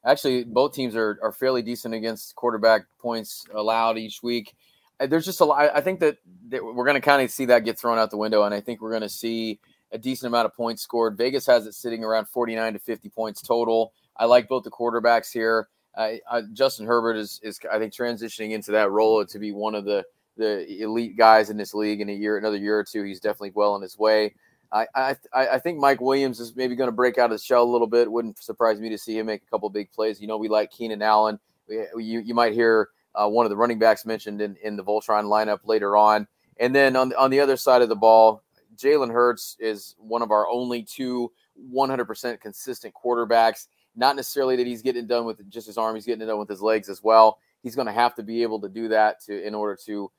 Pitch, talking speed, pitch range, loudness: 115 Hz, 250 wpm, 110-120 Hz, -23 LUFS